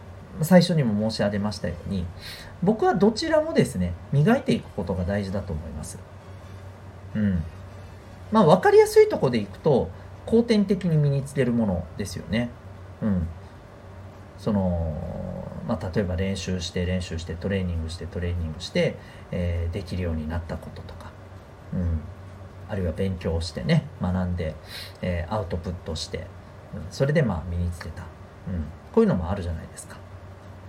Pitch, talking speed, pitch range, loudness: 95 Hz, 320 characters per minute, 90-105 Hz, -25 LUFS